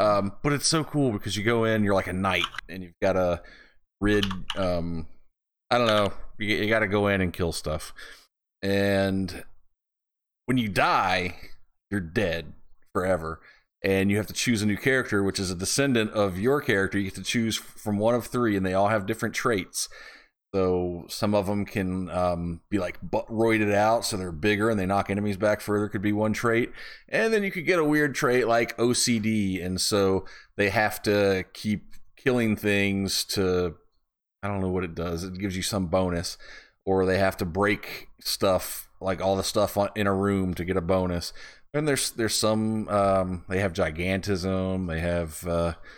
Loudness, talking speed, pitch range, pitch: -26 LUFS, 190 wpm, 95-110 Hz, 100 Hz